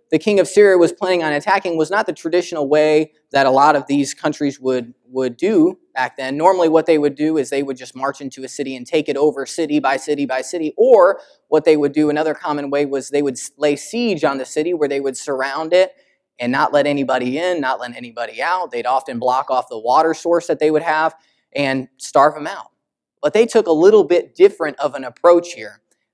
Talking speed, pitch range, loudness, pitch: 235 wpm, 140-170 Hz, -17 LUFS, 150 Hz